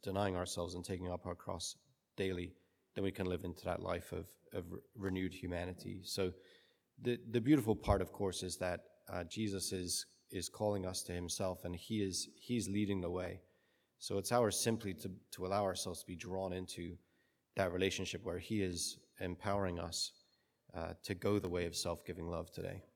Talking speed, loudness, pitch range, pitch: 190 wpm, -40 LUFS, 90-100 Hz, 95 Hz